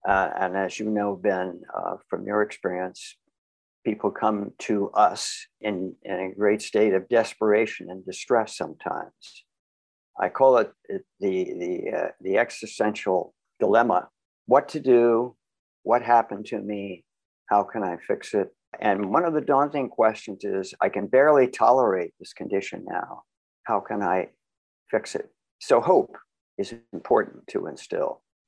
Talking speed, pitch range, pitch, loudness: 150 wpm, 95-120 Hz, 105 Hz, -24 LUFS